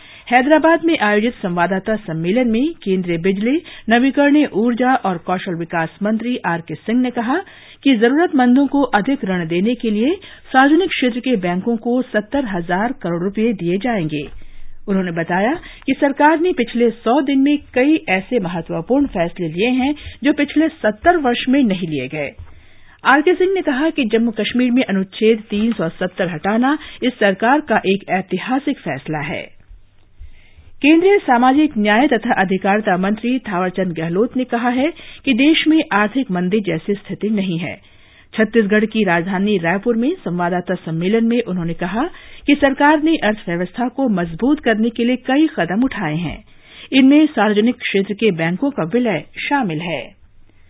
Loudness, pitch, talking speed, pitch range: -17 LUFS, 220 Hz, 155 wpm, 180-265 Hz